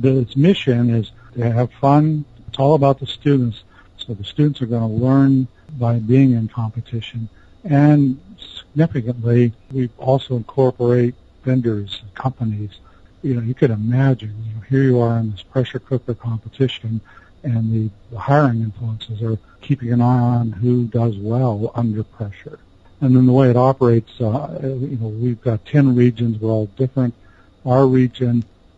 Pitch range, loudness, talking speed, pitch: 110-130 Hz, -18 LUFS, 165 wpm, 120 Hz